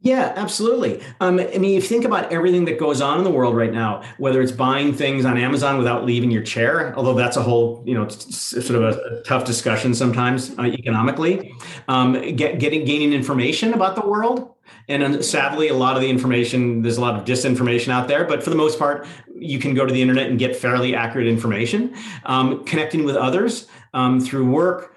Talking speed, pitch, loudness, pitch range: 210 wpm, 130 Hz, -19 LUFS, 125-160 Hz